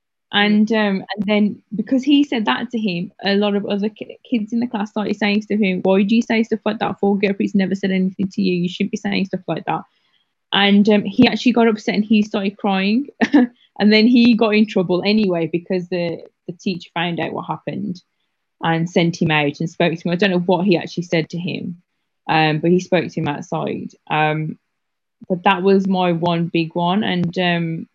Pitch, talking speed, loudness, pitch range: 200 Hz, 220 wpm, -18 LUFS, 175-215 Hz